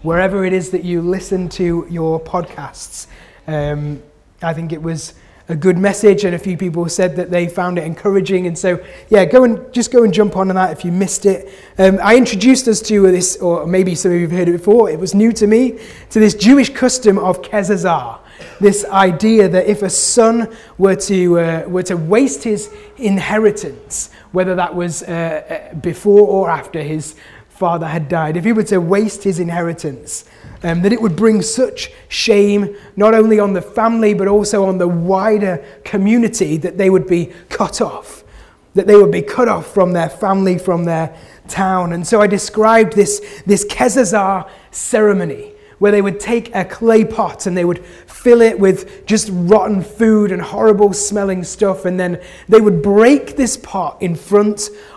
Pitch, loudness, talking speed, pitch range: 195 Hz, -14 LUFS, 190 wpm, 175-215 Hz